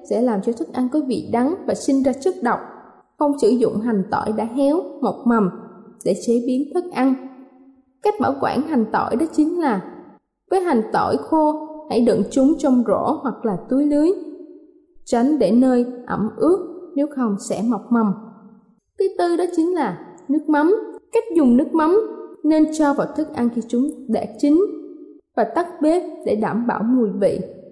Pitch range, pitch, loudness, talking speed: 235-325 Hz, 270 Hz, -20 LUFS, 185 wpm